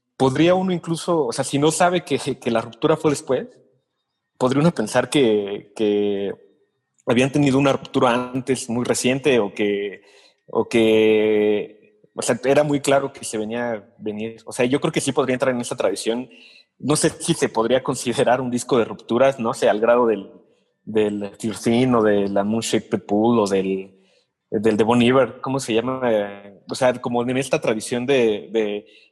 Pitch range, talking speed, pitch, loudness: 110-135 Hz, 190 wpm, 120 Hz, -20 LUFS